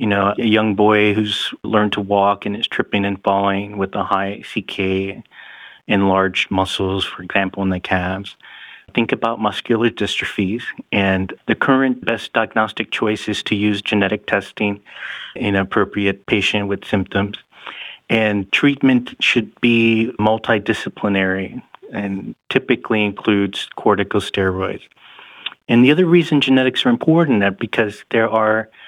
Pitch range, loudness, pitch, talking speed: 100-110 Hz, -18 LUFS, 105 Hz, 135 wpm